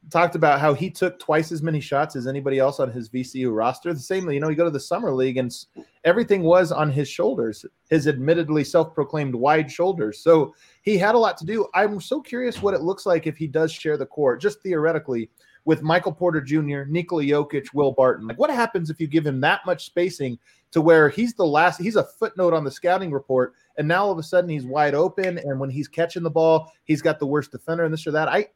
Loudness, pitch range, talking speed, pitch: -22 LUFS, 145-180 Hz, 240 wpm, 160 Hz